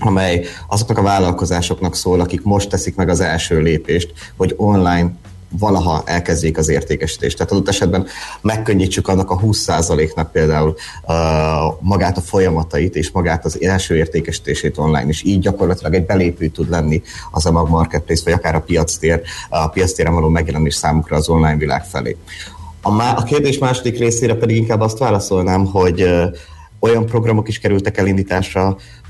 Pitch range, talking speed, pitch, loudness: 80-100 Hz, 155 wpm, 90 Hz, -16 LUFS